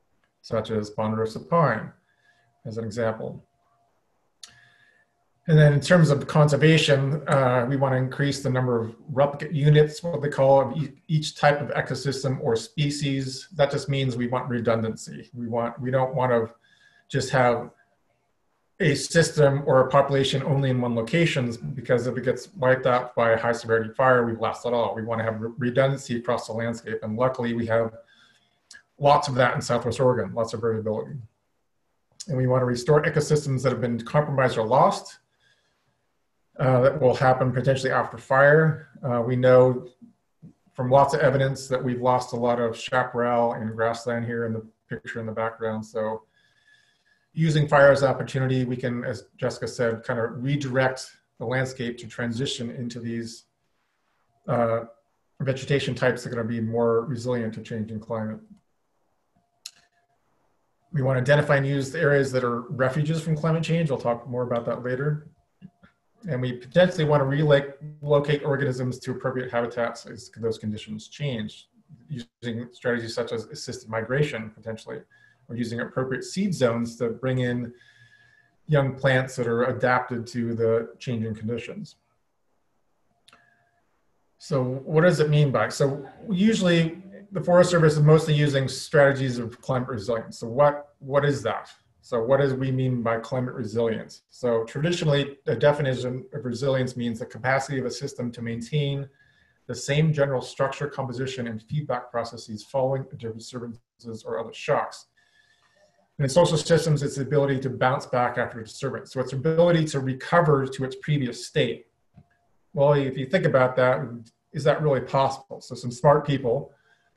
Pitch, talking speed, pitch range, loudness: 130 Hz, 160 wpm, 120-145 Hz, -24 LUFS